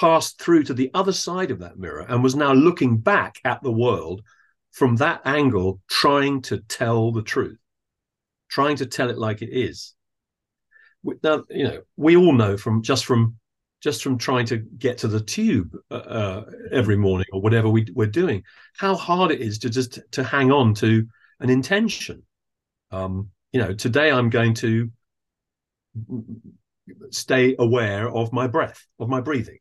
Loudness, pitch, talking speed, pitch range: -21 LUFS, 125 Hz, 170 wpm, 110-140 Hz